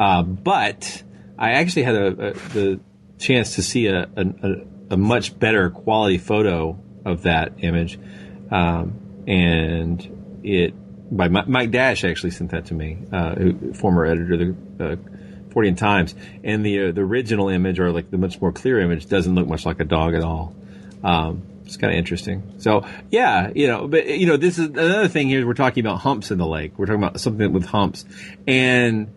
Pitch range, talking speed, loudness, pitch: 85-105 Hz, 195 wpm, -20 LUFS, 95 Hz